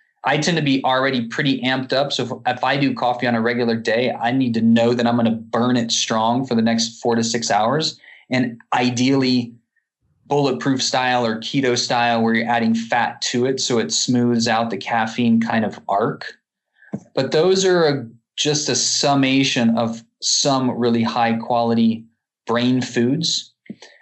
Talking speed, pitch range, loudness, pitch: 180 wpm, 115-130 Hz, -19 LUFS, 120 Hz